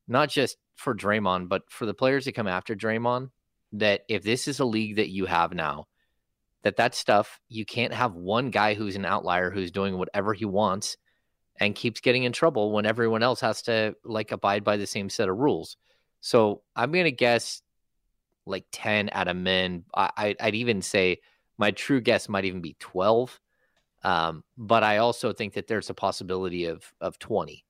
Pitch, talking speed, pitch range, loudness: 105 Hz, 195 wpm, 95-115 Hz, -26 LUFS